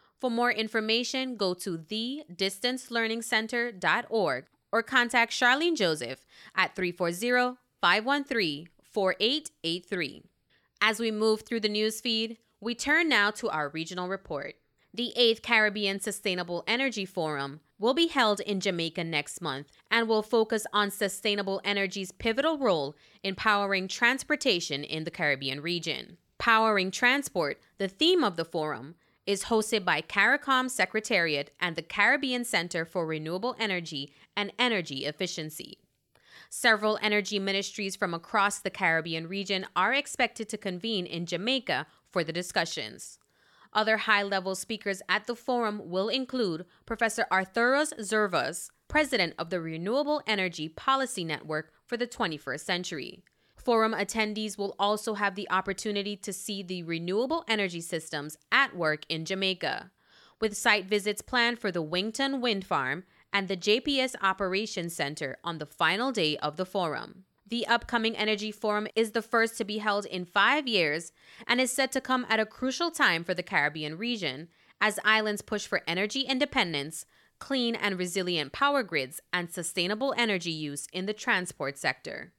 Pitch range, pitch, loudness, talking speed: 180-230 Hz, 205 Hz, -28 LUFS, 145 wpm